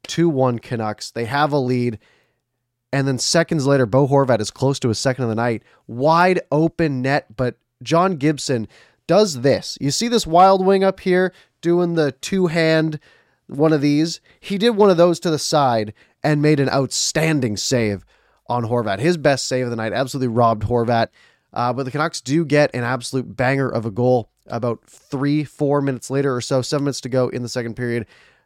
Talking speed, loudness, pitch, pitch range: 195 wpm, -19 LUFS, 135 Hz, 120-155 Hz